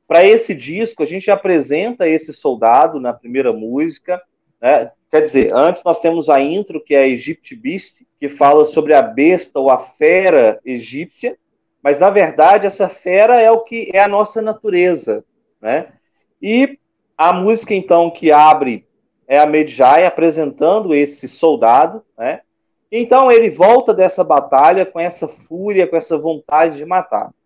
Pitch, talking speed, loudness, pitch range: 180 Hz, 155 wpm, -13 LUFS, 155-220 Hz